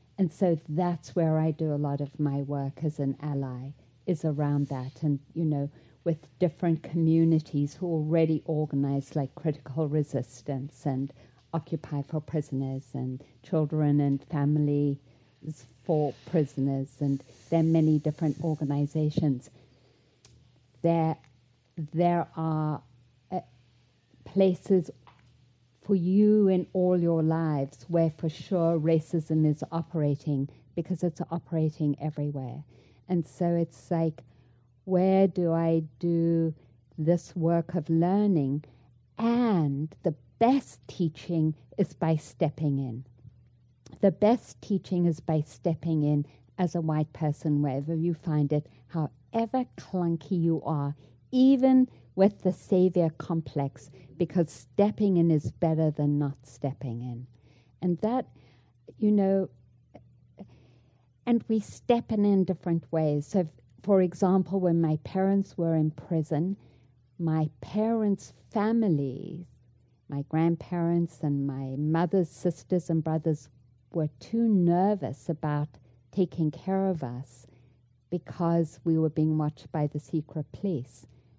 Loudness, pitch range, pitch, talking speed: -28 LUFS, 135-170 Hz, 155 Hz, 125 wpm